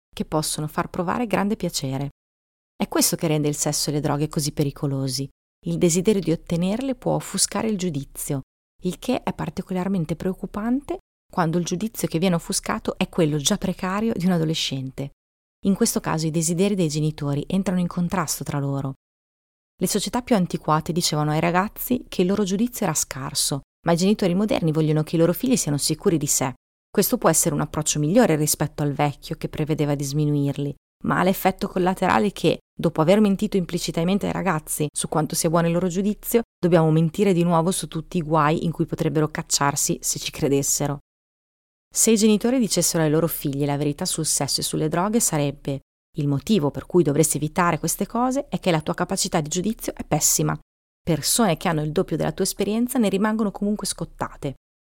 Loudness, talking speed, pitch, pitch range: -22 LUFS, 185 wpm, 170 Hz, 150-195 Hz